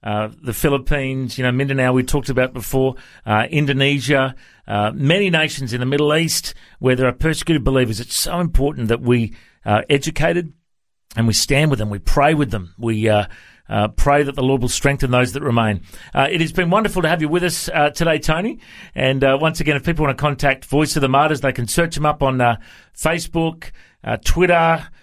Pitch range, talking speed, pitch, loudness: 125-155 Hz, 215 wpm, 140 Hz, -18 LUFS